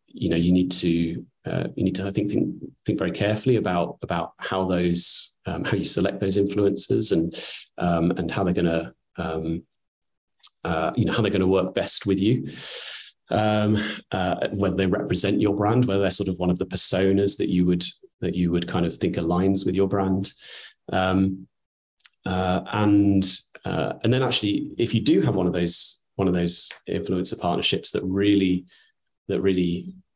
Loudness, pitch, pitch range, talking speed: -24 LUFS, 95 Hz, 90-100 Hz, 185 wpm